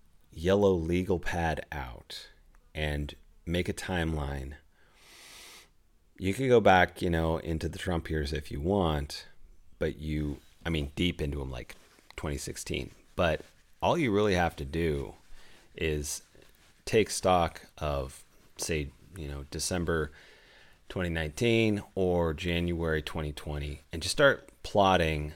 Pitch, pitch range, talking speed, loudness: 80 Hz, 75-90 Hz, 125 wpm, -30 LUFS